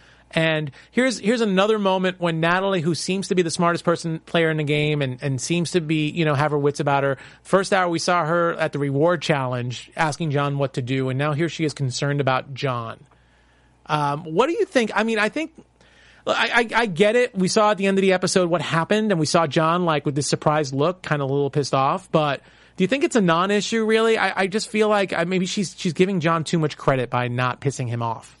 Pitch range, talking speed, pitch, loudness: 145-190 Hz, 245 wpm, 165 Hz, -21 LUFS